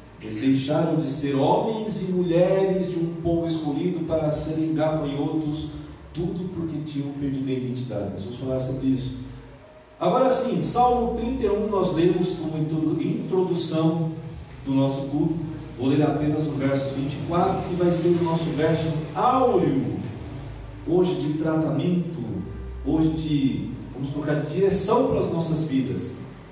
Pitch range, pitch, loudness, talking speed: 135-175 Hz, 155 Hz, -24 LUFS, 140 wpm